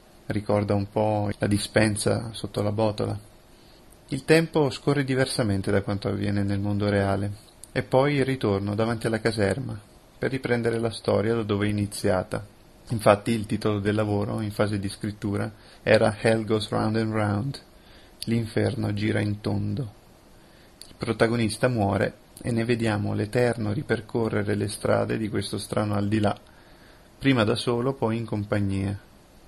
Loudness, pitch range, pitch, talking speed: -26 LUFS, 100-115 Hz, 105 Hz, 150 wpm